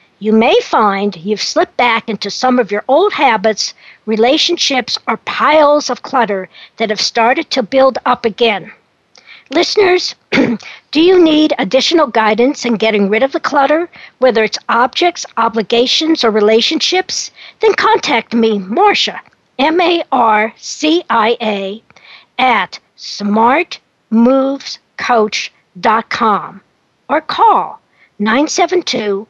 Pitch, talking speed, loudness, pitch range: 245 Hz, 120 wpm, -12 LUFS, 220-305 Hz